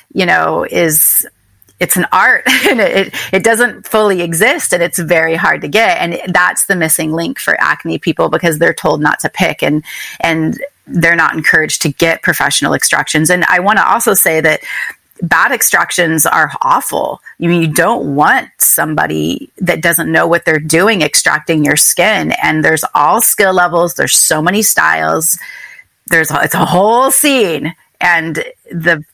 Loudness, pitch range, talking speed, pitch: -10 LUFS, 160-190 Hz, 175 wpm, 170 Hz